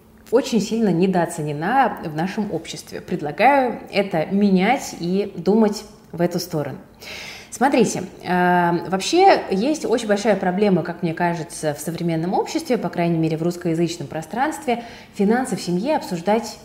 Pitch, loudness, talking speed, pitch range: 190 Hz, -20 LUFS, 130 wpm, 170-220 Hz